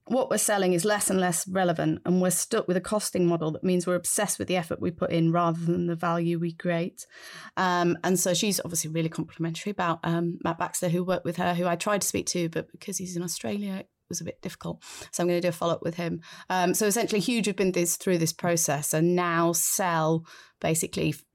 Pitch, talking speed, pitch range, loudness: 175 Hz, 240 wpm, 170-185 Hz, -26 LUFS